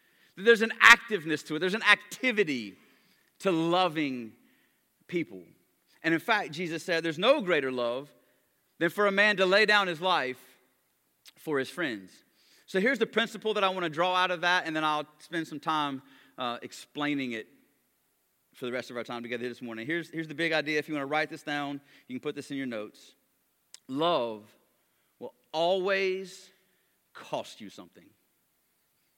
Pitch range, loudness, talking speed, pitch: 140-190 Hz, -28 LUFS, 180 wpm, 165 Hz